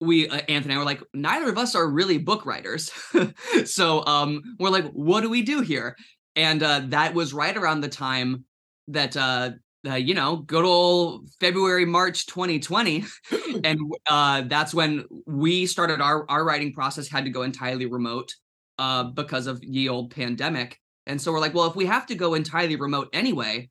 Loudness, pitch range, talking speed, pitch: -23 LUFS, 135-175 Hz, 190 wpm, 150 Hz